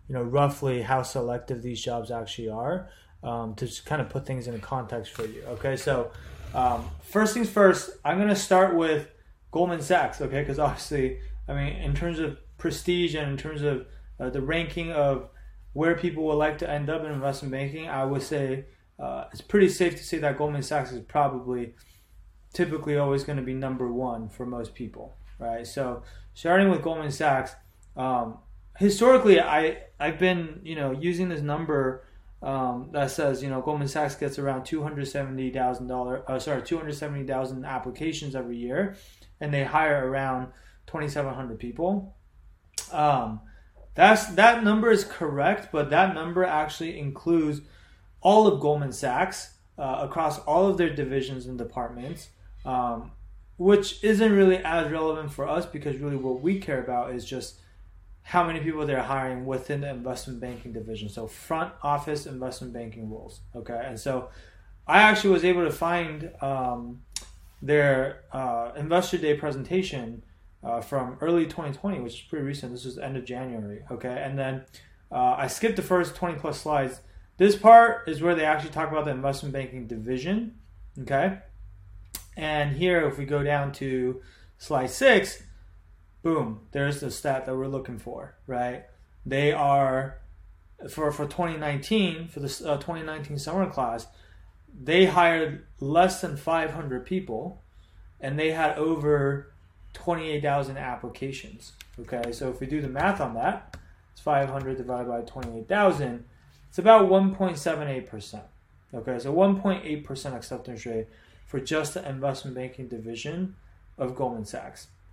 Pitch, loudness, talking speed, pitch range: 140 Hz, -26 LUFS, 155 wpm, 120-160 Hz